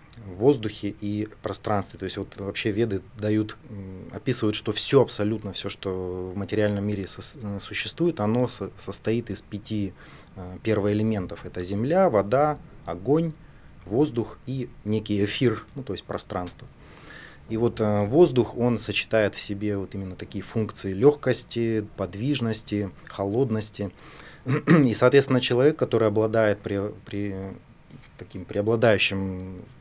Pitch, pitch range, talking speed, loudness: 105 Hz, 100-120 Hz, 130 wpm, -25 LUFS